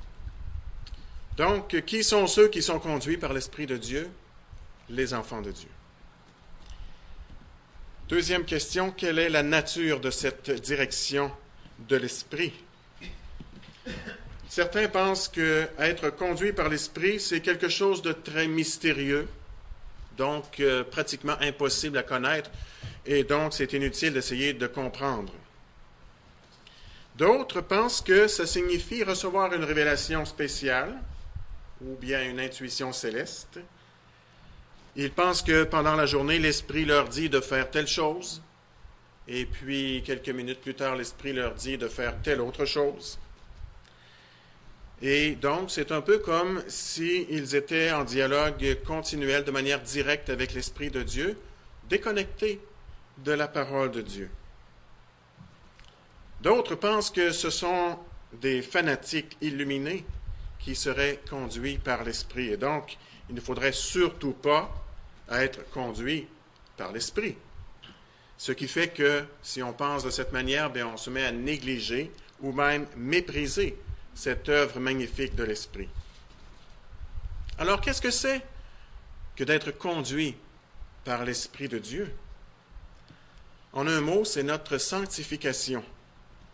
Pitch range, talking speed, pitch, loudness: 120-155 Hz, 125 wpm, 140 Hz, -28 LUFS